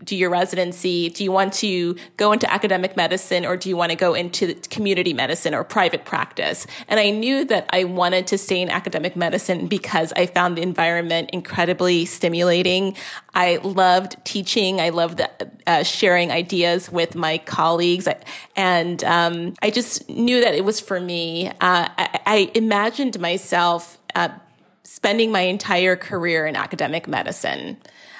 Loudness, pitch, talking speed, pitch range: -20 LUFS, 180 Hz, 165 wpm, 175-200 Hz